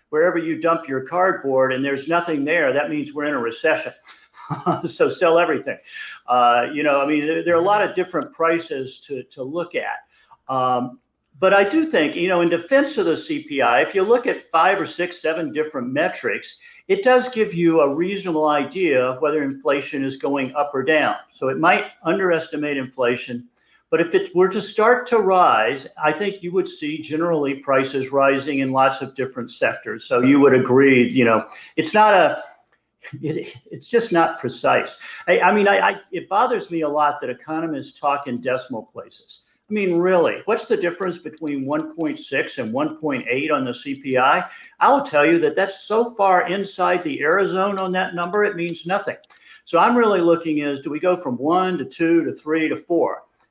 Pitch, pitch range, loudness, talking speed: 165 Hz, 140-195 Hz, -20 LUFS, 195 wpm